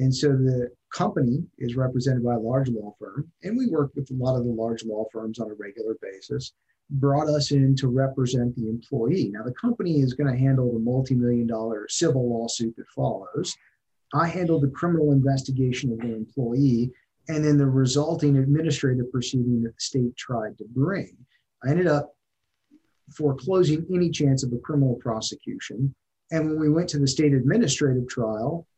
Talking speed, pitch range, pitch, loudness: 180 wpm, 120-145 Hz, 130 Hz, -24 LUFS